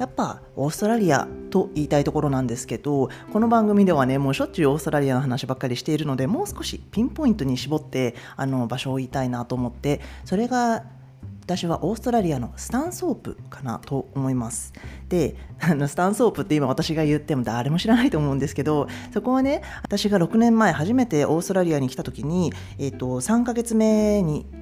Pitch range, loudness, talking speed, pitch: 130-200 Hz, -23 LUFS, 425 characters per minute, 145 Hz